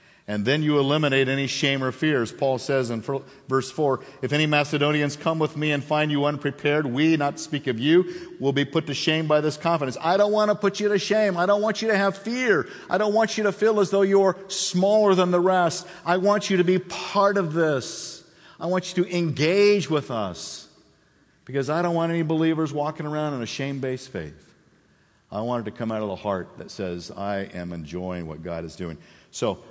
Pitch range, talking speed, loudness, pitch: 135-185 Hz, 225 wpm, -23 LUFS, 150 Hz